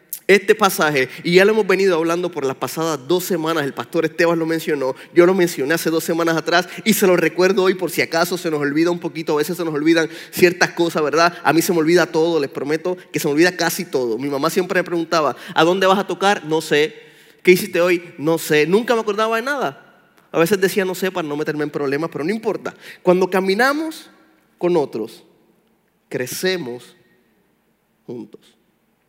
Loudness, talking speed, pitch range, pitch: -18 LUFS, 210 wpm, 160-185 Hz, 170 Hz